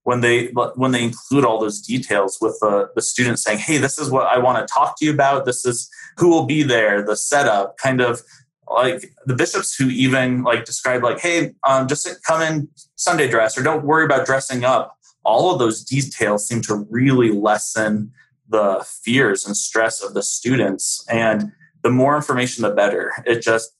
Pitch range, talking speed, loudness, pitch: 115-140 Hz, 200 wpm, -18 LUFS, 125 Hz